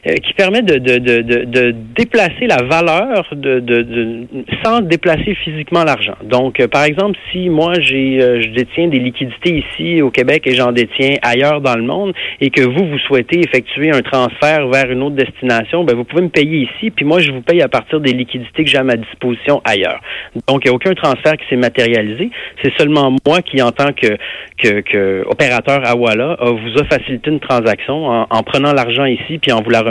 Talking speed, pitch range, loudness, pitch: 210 wpm, 120-155 Hz, -13 LUFS, 135 Hz